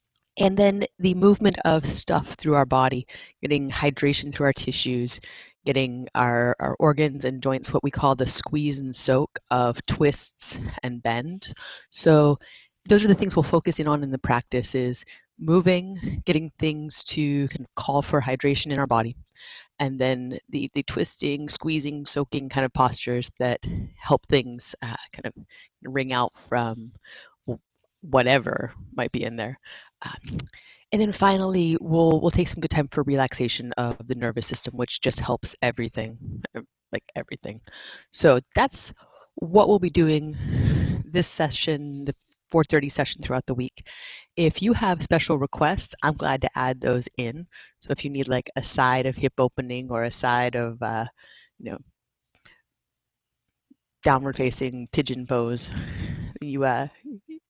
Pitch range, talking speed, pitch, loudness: 125-155 Hz, 155 wpm, 135 Hz, -24 LUFS